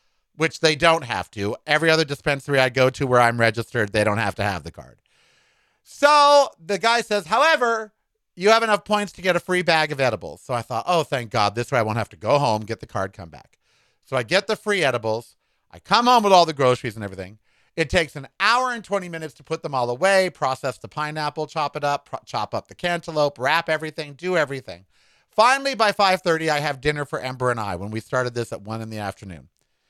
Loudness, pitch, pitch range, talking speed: -21 LUFS, 150 Hz, 120-185 Hz, 235 wpm